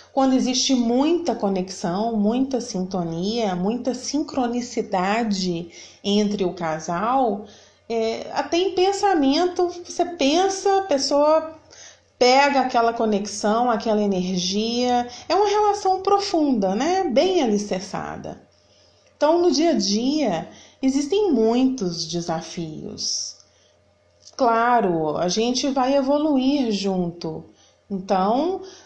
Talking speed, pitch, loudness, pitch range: 95 wpm, 240 Hz, -21 LUFS, 195-290 Hz